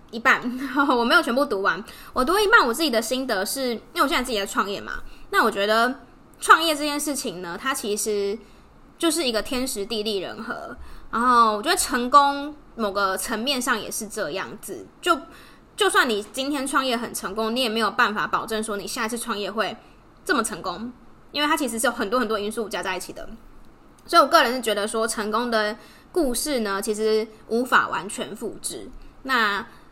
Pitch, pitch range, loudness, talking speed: 235 Hz, 215-280 Hz, -23 LUFS, 290 characters per minute